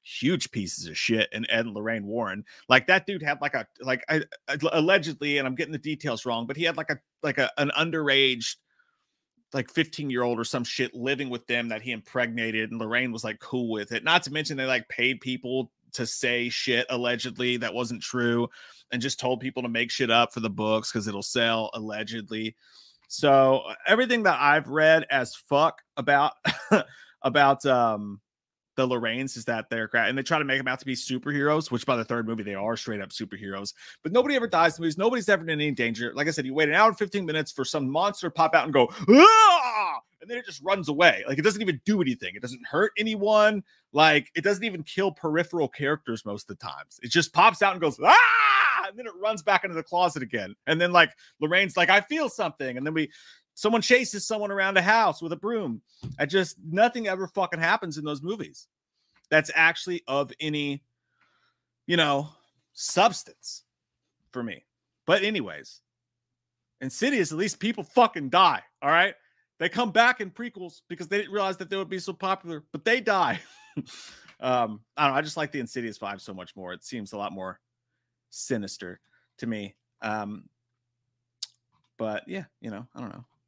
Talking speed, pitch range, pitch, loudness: 205 wpm, 120-185 Hz, 145 Hz, -24 LUFS